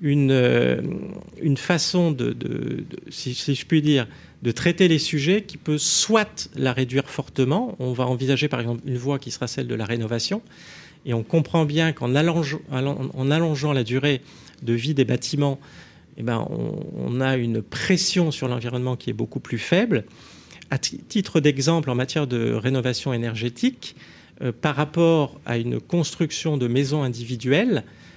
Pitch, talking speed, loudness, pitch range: 140 Hz, 170 wpm, -23 LUFS, 125-160 Hz